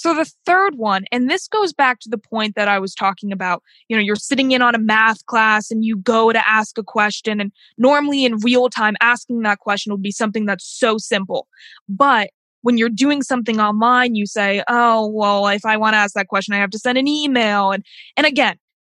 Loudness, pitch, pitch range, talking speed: -17 LUFS, 225 Hz, 205-250 Hz, 230 wpm